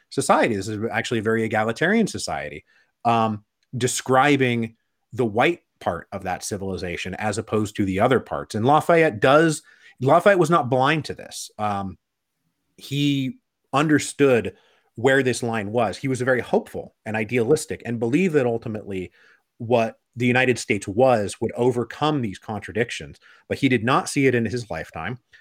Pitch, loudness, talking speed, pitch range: 120 Hz, -22 LUFS, 160 wpm, 110-135 Hz